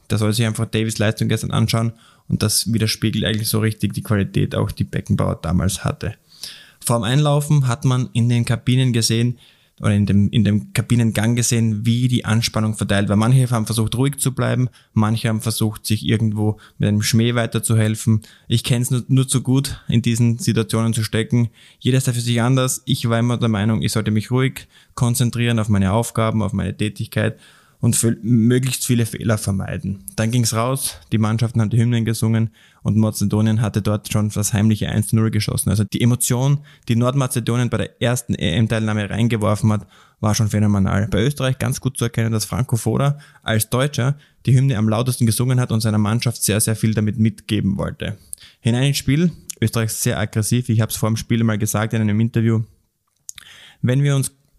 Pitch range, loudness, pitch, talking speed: 110-120 Hz, -19 LUFS, 115 Hz, 190 wpm